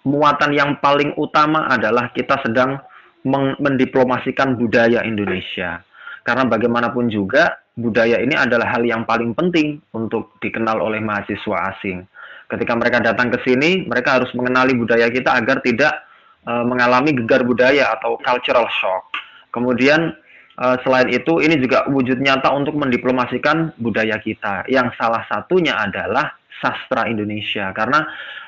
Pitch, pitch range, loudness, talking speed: 125 Hz, 115-135 Hz, -17 LUFS, 135 wpm